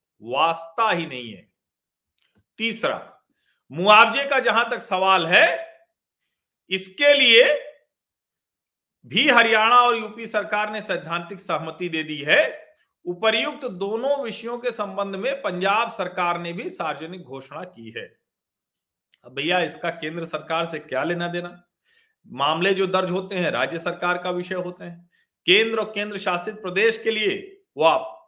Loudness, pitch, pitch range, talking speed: -21 LUFS, 195 Hz, 175-240 Hz, 135 wpm